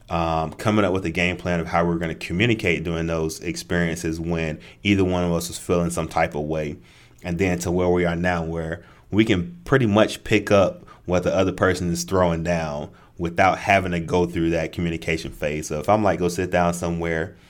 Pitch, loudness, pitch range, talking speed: 85 Hz, -22 LUFS, 80-90 Hz, 220 wpm